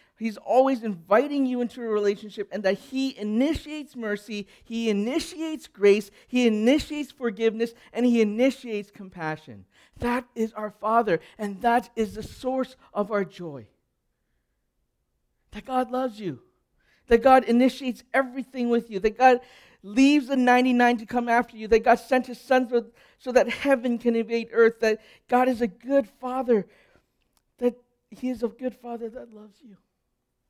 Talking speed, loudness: 155 wpm, -24 LUFS